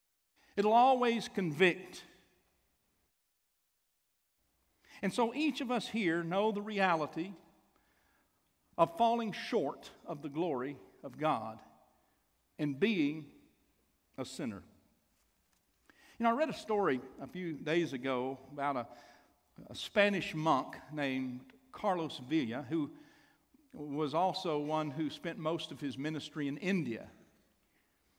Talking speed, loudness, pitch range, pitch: 115 wpm, -34 LUFS, 140-205 Hz, 160 Hz